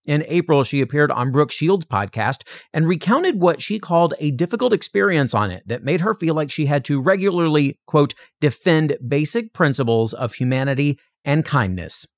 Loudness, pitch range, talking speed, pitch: -19 LUFS, 135-170 Hz, 170 wpm, 150 Hz